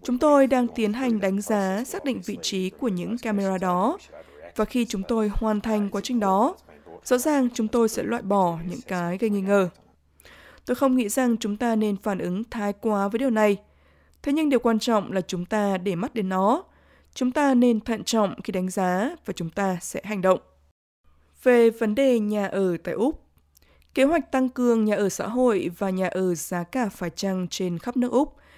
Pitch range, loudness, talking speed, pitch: 190-245 Hz, -24 LUFS, 215 wpm, 210 Hz